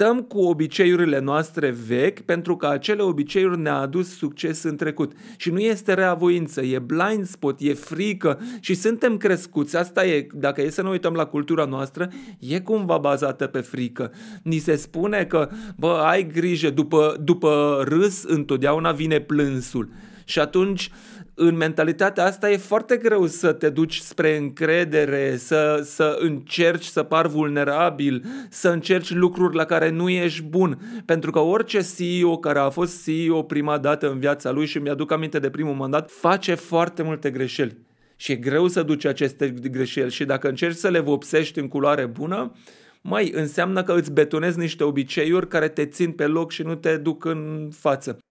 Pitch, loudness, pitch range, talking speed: 160 Hz, -22 LUFS, 145-180 Hz, 170 wpm